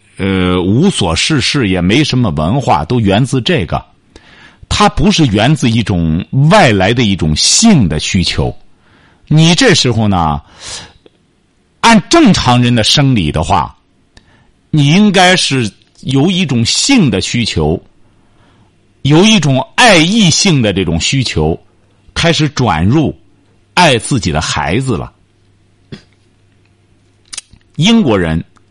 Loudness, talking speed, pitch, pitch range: -10 LUFS, 170 characters per minute, 105 Hz, 95-145 Hz